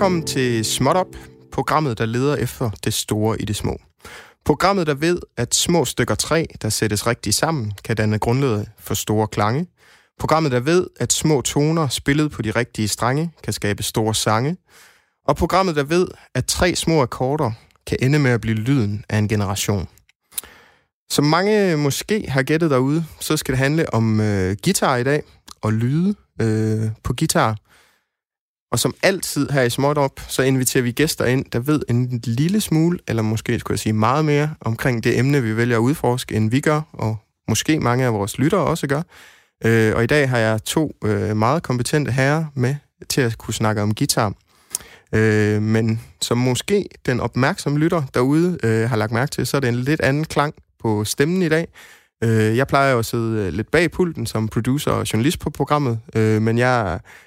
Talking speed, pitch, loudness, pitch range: 190 wpm, 125 Hz, -20 LUFS, 110-150 Hz